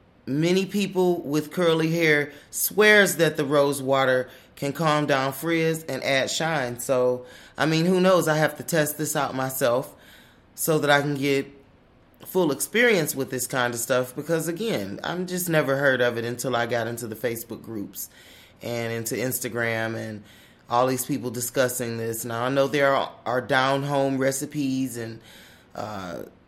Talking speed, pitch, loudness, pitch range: 170 wpm, 135 Hz, -24 LUFS, 125-155 Hz